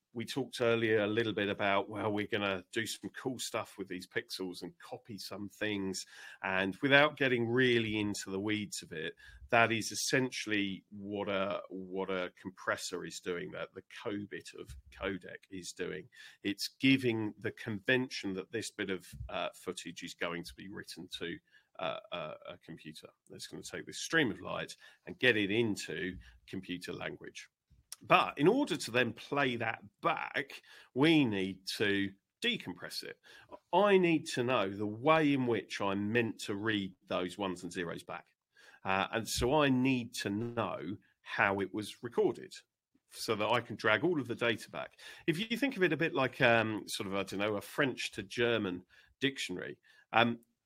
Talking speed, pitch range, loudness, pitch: 180 wpm, 95-120 Hz, -34 LUFS, 105 Hz